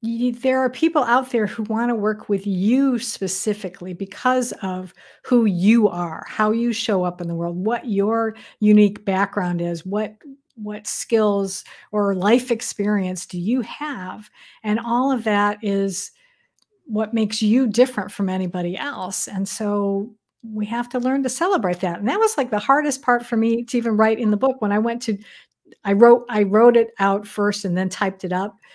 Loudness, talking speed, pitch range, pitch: -20 LUFS, 190 wpm, 200-240 Hz, 215 Hz